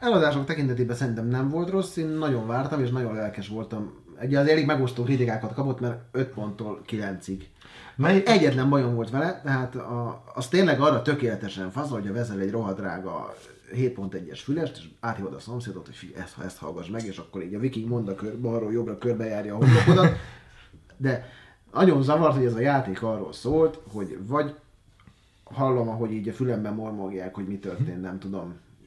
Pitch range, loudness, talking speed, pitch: 100-135 Hz, -26 LUFS, 180 wpm, 120 Hz